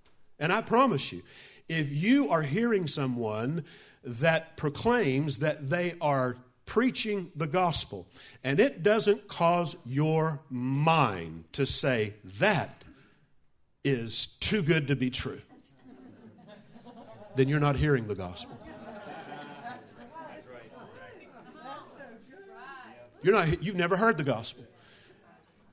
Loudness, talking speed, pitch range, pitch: -28 LUFS, 105 wpm, 125-180 Hz, 150 Hz